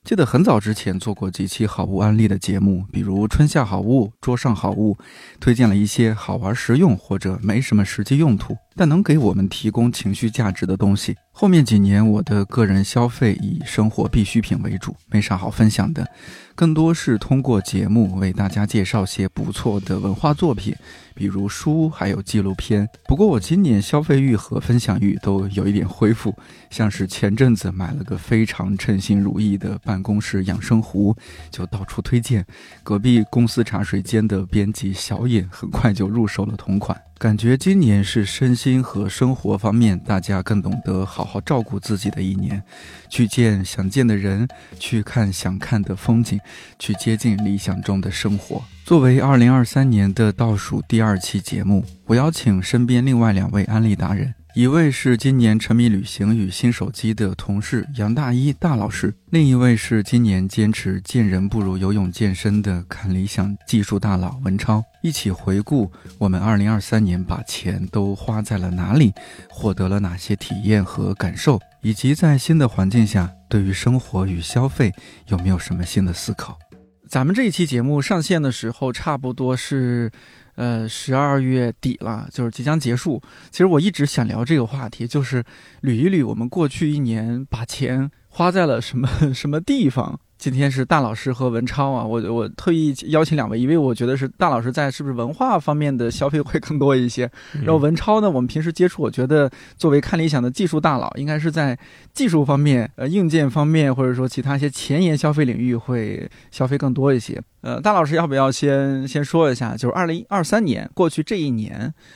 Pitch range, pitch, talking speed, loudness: 100-135 Hz, 115 Hz, 285 characters per minute, -19 LUFS